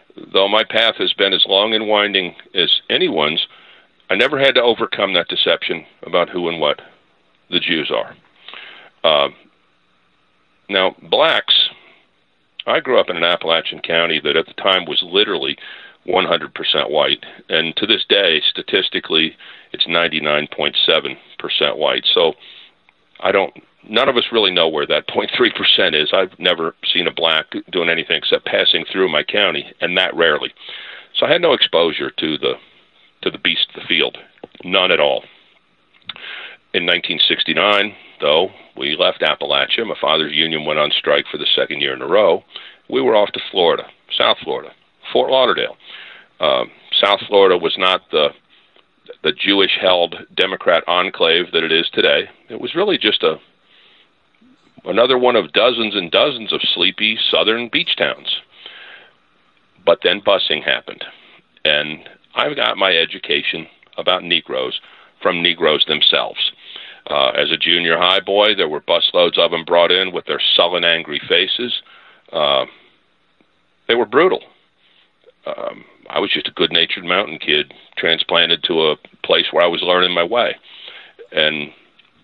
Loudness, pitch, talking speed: -16 LUFS, 110 Hz, 150 wpm